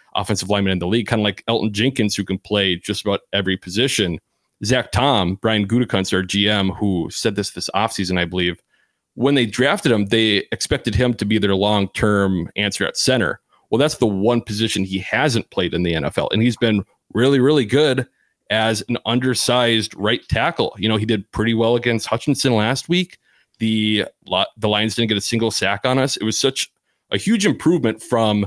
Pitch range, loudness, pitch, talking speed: 100-120 Hz, -19 LUFS, 110 Hz, 195 wpm